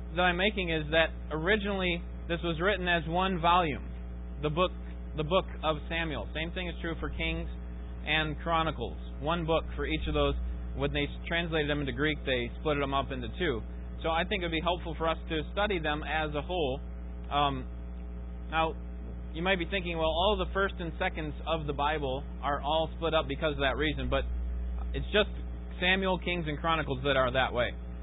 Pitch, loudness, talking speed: 155 Hz, -31 LUFS, 200 wpm